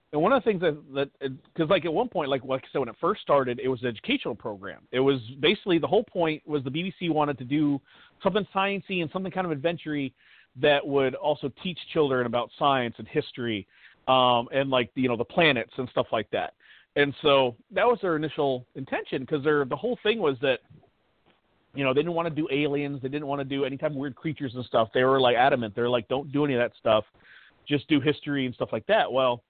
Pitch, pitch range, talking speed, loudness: 140 Hz, 130-155 Hz, 240 wpm, -26 LUFS